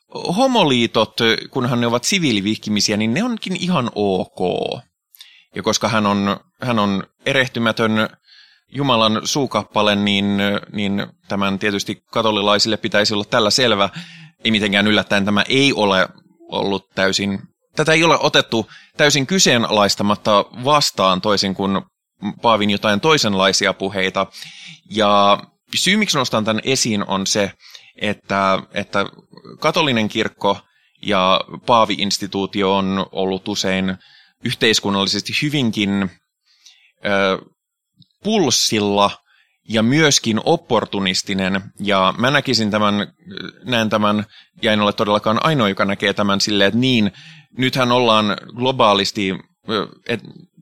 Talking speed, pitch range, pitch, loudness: 110 wpm, 100-125 Hz, 105 Hz, -17 LUFS